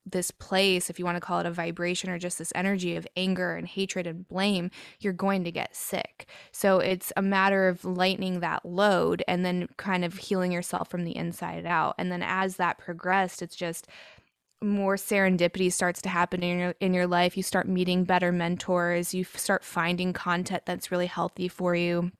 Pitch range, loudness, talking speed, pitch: 175-190 Hz, -28 LUFS, 200 wpm, 180 Hz